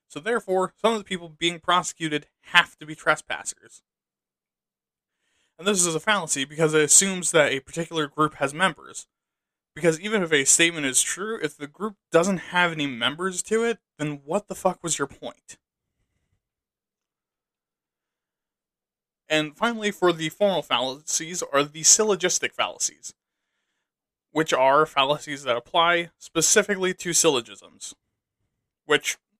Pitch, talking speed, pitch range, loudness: 170 Hz, 140 wpm, 150-190 Hz, -22 LUFS